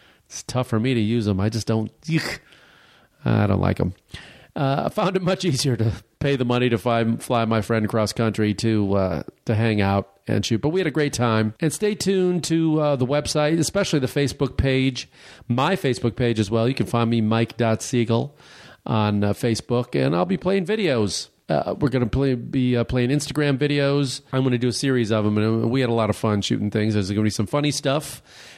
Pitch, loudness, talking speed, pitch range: 120 Hz, -22 LUFS, 225 wpm, 110-145 Hz